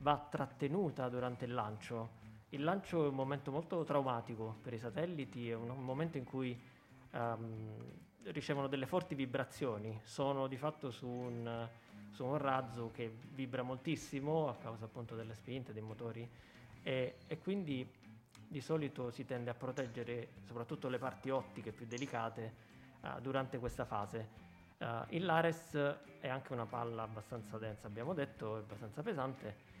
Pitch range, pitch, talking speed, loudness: 115-140 Hz, 125 Hz, 155 wpm, -42 LUFS